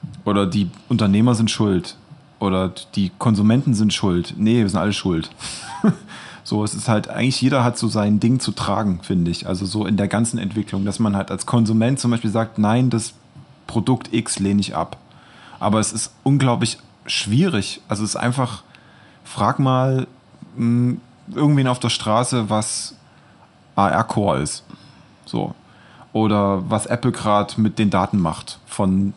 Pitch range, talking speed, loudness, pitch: 100-120 Hz, 165 wpm, -20 LUFS, 110 Hz